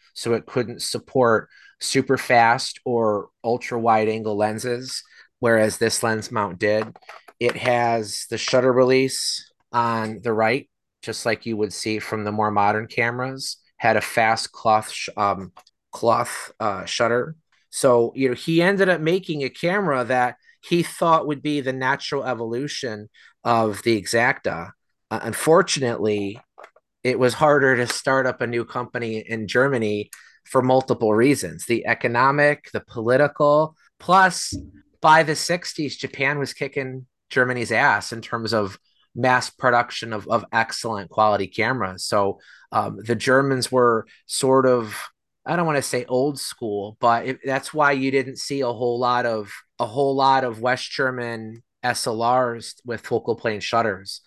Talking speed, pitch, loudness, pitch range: 155 wpm, 120 Hz, -21 LUFS, 110-135 Hz